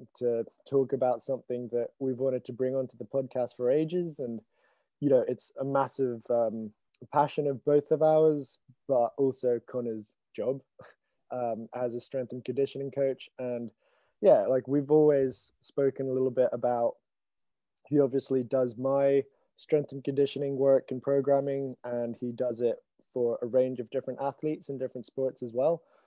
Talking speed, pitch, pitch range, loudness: 165 wpm, 130 Hz, 125-140 Hz, -29 LUFS